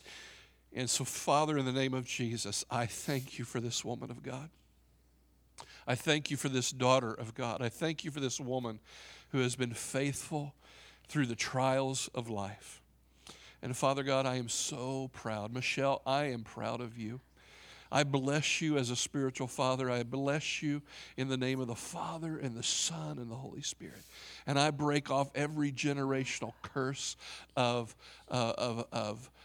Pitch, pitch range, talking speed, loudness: 130 Hz, 120-140 Hz, 175 wpm, -35 LUFS